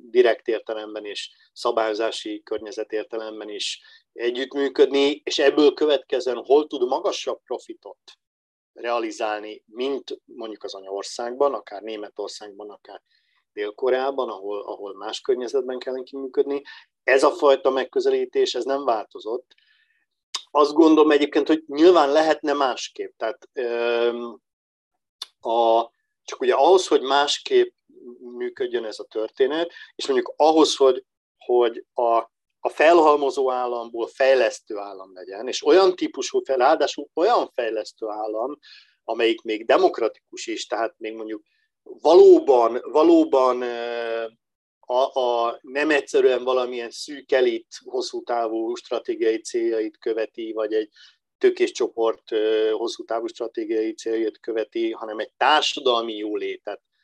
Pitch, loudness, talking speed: 355 Hz, -22 LUFS, 115 wpm